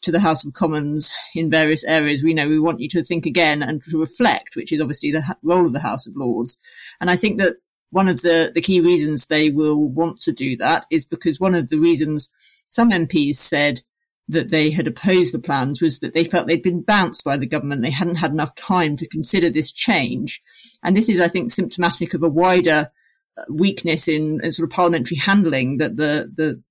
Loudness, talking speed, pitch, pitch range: -18 LUFS, 220 wpm, 165 Hz, 155-175 Hz